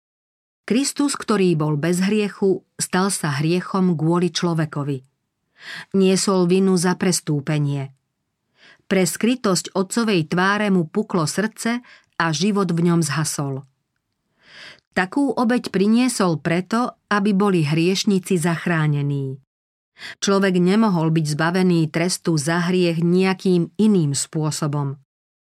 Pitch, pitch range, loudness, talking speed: 180 Hz, 160-195 Hz, -20 LUFS, 105 wpm